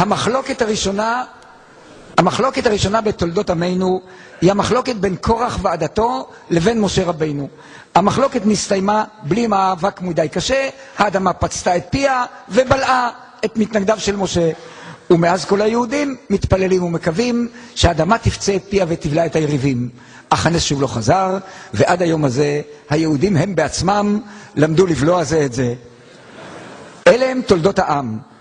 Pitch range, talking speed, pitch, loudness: 160-220 Hz, 130 wpm, 190 Hz, -17 LUFS